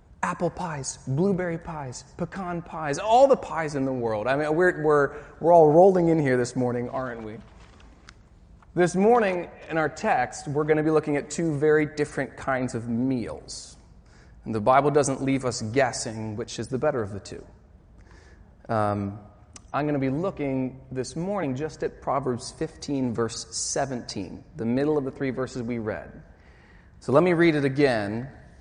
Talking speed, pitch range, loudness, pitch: 175 wpm, 115-155 Hz, -25 LUFS, 135 Hz